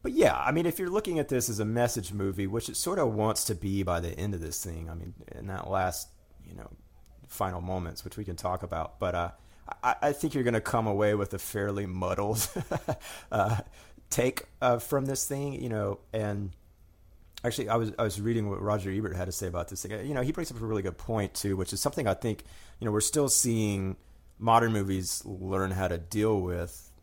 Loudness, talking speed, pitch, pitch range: -30 LUFS, 235 wpm, 100 Hz, 90-115 Hz